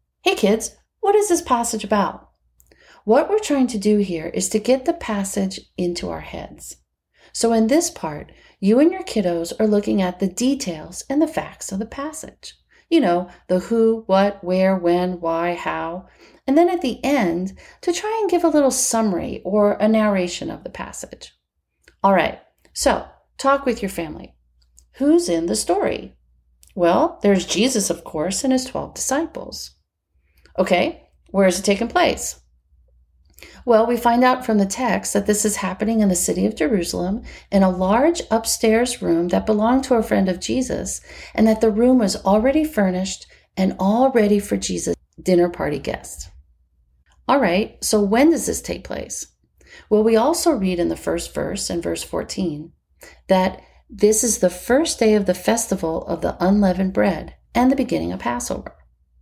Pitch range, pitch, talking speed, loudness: 175-245 Hz, 205 Hz, 175 wpm, -20 LUFS